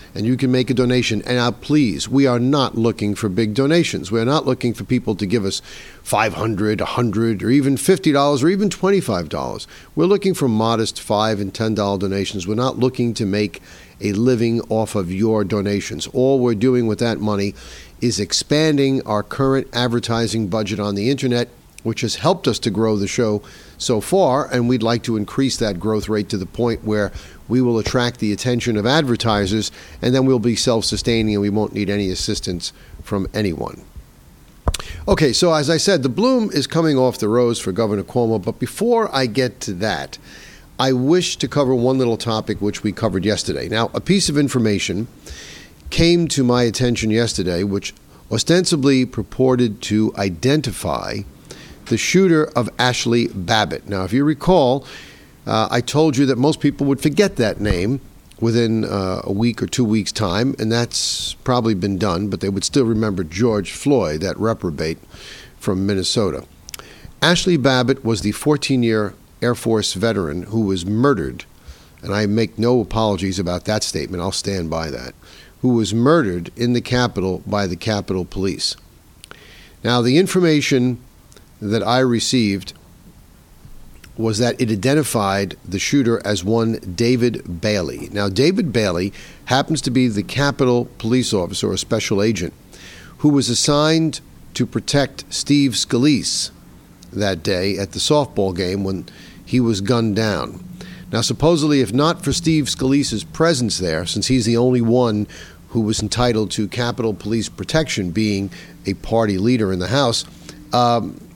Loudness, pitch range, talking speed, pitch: -18 LUFS, 100-130 Hz, 170 wpm, 115 Hz